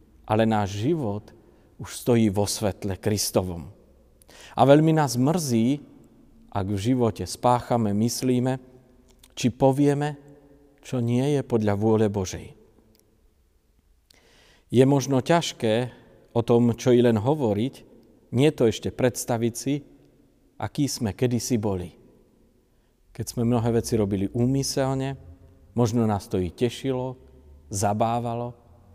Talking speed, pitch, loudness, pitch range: 115 wpm, 115 Hz, -24 LUFS, 100-130 Hz